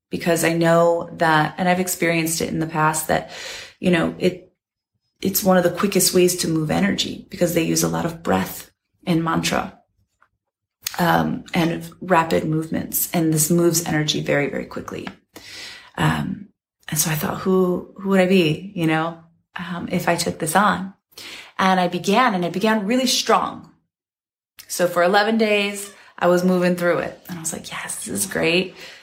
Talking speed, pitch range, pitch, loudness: 180 wpm, 165-190 Hz, 175 Hz, -20 LUFS